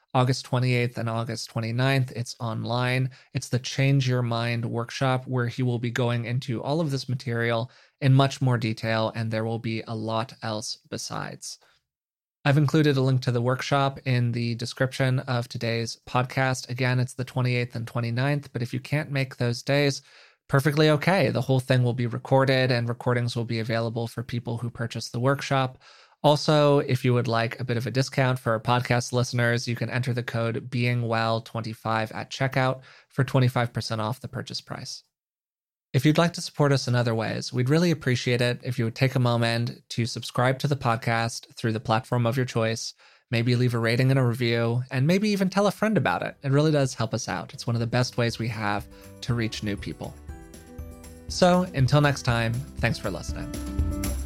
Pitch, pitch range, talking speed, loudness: 120 Hz, 115-135 Hz, 195 wpm, -25 LUFS